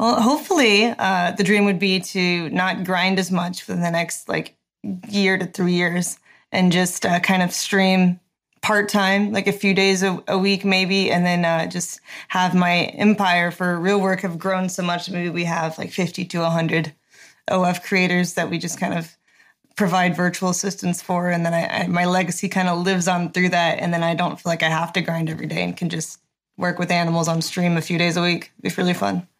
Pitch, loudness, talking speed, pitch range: 180 Hz, -20 LUFS, 220 wpm, 175-190 Hz